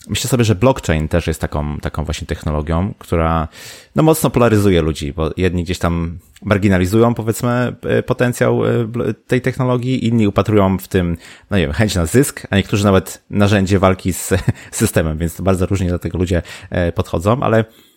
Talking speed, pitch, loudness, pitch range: 165 wpm, 95 Hz, -16 LUFS, 85-115 Hz